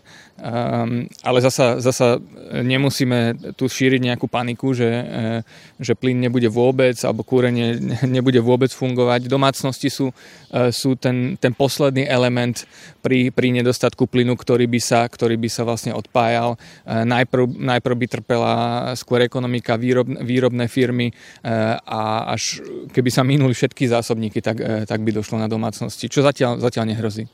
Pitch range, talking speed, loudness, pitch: 115-130 Hz, 140 wpm, -19 LUFS, 125 Hz